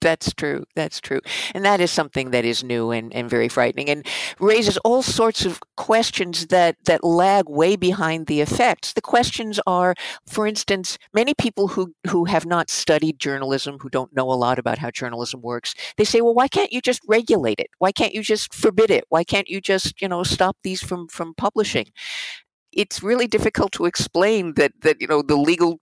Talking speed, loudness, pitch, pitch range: 200 wpm, -20 LUFS, 180 Hz, 155-215 Hz